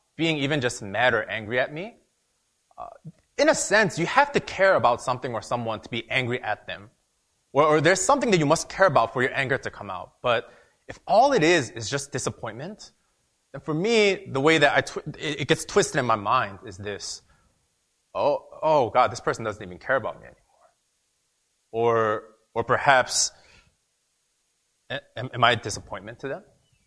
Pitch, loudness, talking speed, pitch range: 140 Hz, -23 LUFS, 190 wpm, 115-165 Hz